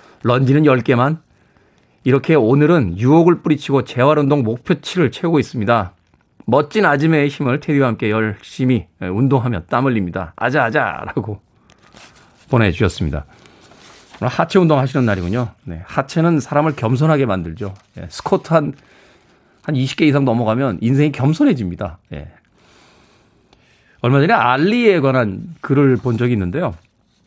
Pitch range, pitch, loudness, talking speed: 110-150 Hz, 130 Hz, -16 LUFS, 305 characters per minute